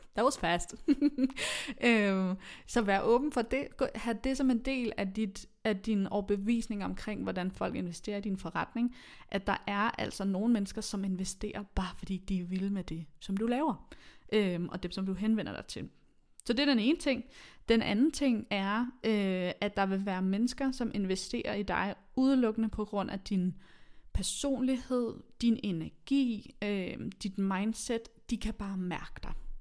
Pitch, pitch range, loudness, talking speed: 210 Hz, 195-240 Hz, -33 LUFS, 180 wpm